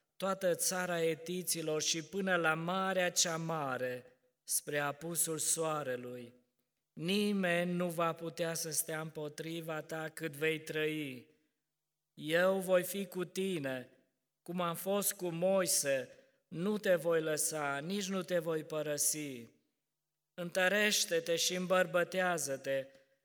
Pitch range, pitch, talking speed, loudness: 150-180 Hz, 165 Hz, 115 wpm, -34 LUFS